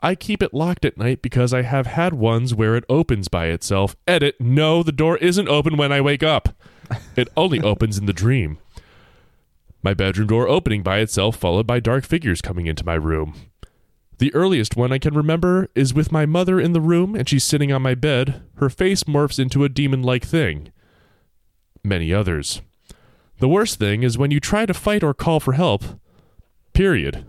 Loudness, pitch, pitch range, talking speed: -19 LUFS, 135 Hz, 110-160 Hz, 195 wpm